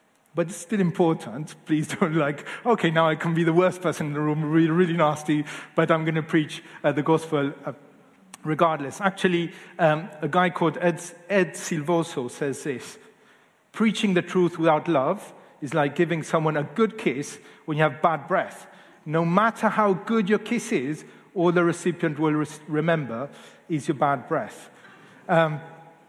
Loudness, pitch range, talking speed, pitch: -24 LUFS, 155-180 Hz, 175 wpm, 165 Hz